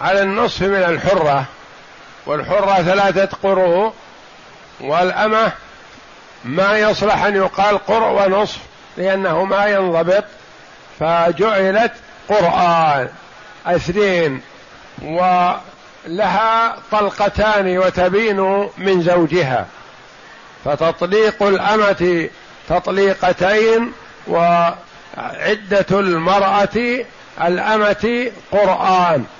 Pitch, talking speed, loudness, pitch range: 195 Hz, 65 wpm, -16 LUFS, 180-210 Hz